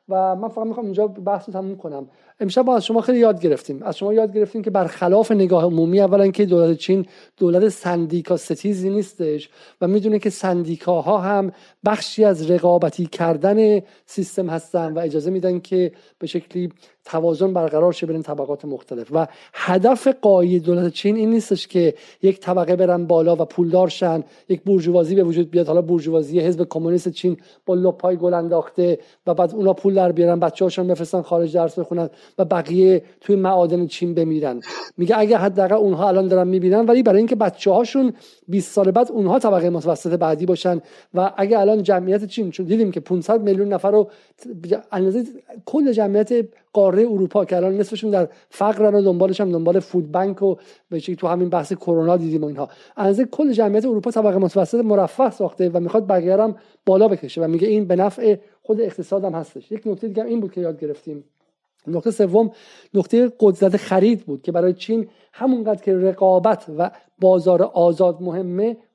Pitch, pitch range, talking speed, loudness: 185 Hz, 175-210 Hz, 175 wpm, -19 LUFS